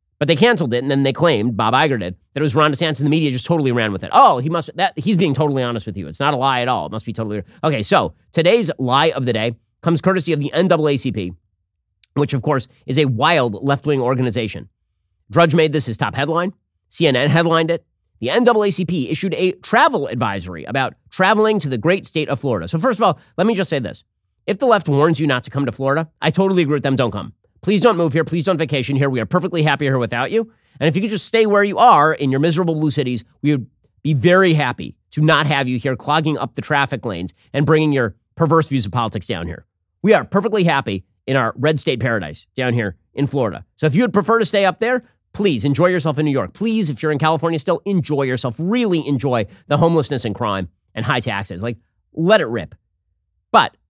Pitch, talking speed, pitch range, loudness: 145 Hz, 240 wpm, 120-170 Hz, -17 LUFS